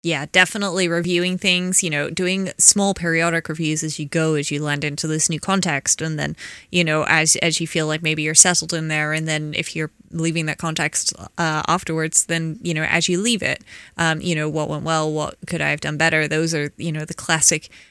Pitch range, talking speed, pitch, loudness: 155-170 Hz, 230 wpm, 160 Hz, -19 LUFS